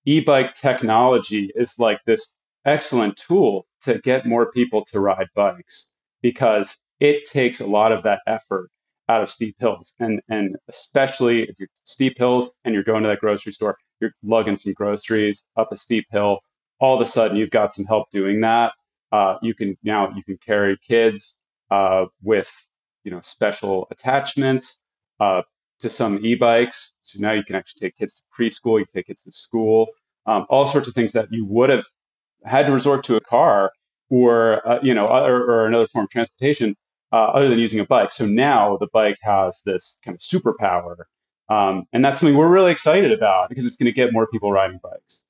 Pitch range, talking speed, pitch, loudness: 105-125 Hz, 195 wpm, 115 Hz, -19 LUFS